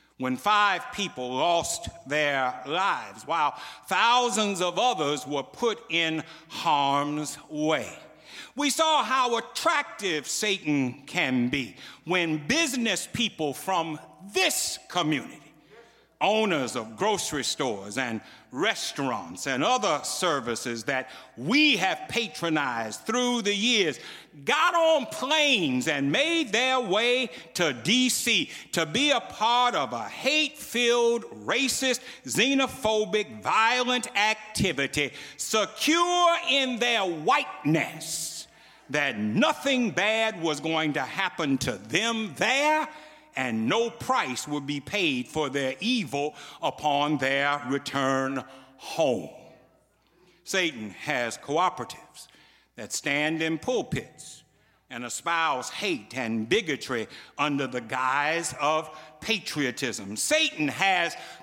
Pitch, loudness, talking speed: 180 Hz, -26 LUFS, 110 wpm